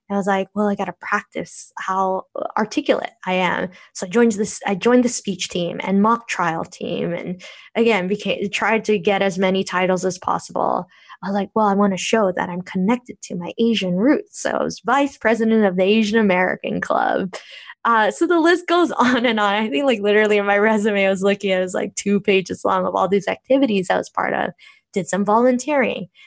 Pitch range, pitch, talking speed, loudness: 190-230 Hz, 205 Hz, 220 wpm, -19 LUFS